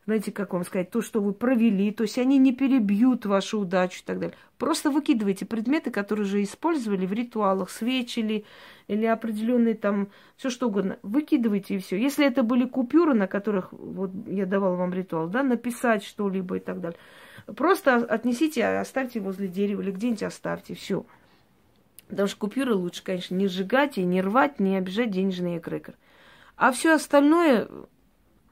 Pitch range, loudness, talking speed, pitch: 195-255 Hz, -25 LUFS, 165 wpm, 215 Hz